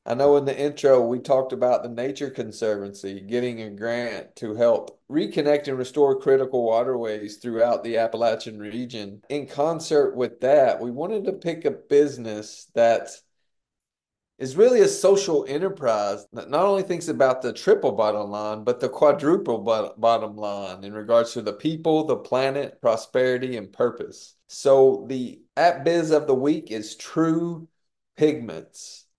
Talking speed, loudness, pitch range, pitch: 155 wpm, -23 LUFS, 115-145 Hz, 125 Hz